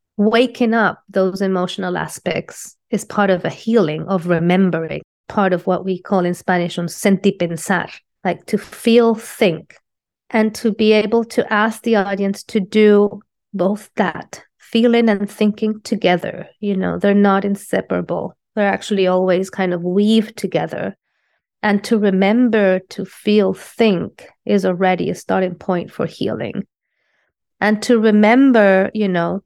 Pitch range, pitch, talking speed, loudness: 185-220 Hz, 200 Hz, 145 wpm, -17 LUFS